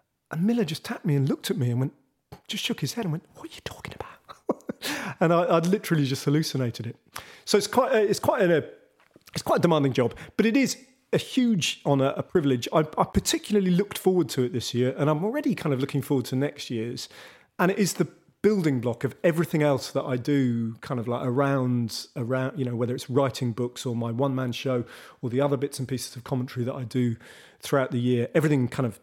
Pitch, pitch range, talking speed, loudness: 140 Hz, 125-170 Hz, 230 wpm, -26 LUFS